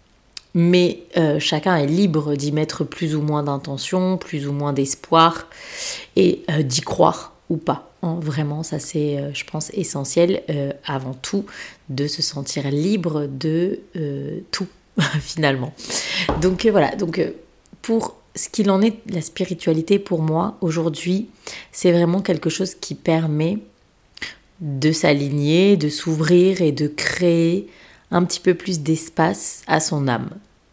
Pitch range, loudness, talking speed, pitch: 150-185 Hz, -20 LUFS, 145 wpm, 165 Hz